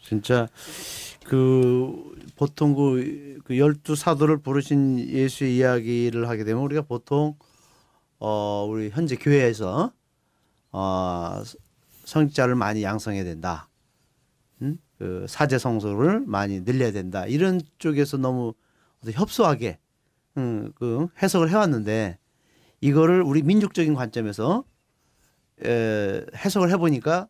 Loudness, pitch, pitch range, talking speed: -24 LUFS, 130 Hz, 110-155 Hz, 235 characters per minute